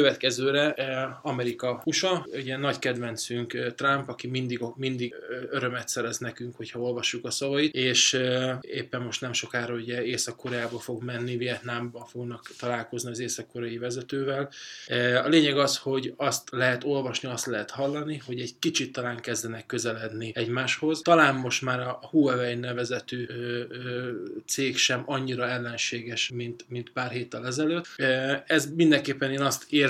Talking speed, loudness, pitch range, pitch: 135 wpm, -28 LUFS, 120-135 Hz, 125 Hz